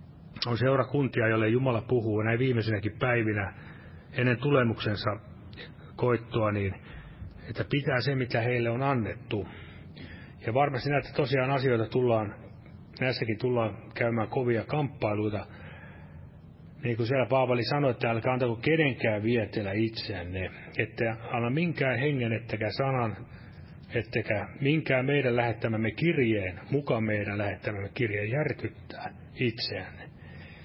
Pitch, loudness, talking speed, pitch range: 115 Hz, -29 LUFS, 115 wpm, 105-130 Hz